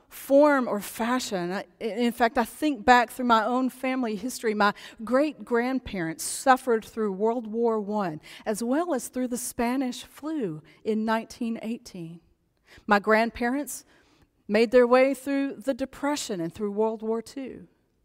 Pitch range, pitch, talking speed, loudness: 220-260 Hz, 235 Hz, 145 wpm, -26 LUFS